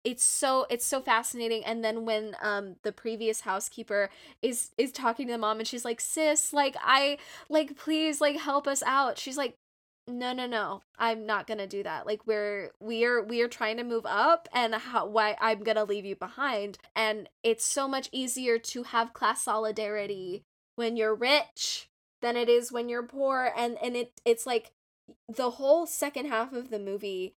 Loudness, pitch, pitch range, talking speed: -29 LUFS, 235 Hz, 220-260 Hz, 195 wpm